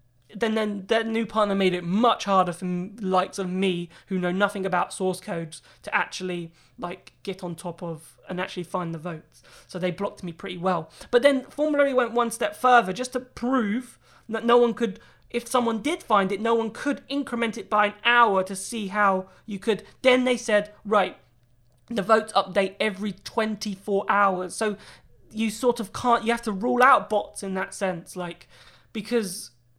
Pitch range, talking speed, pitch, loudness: 185-230 Hz, 195 wpm, 205 Hz, -25 LUFS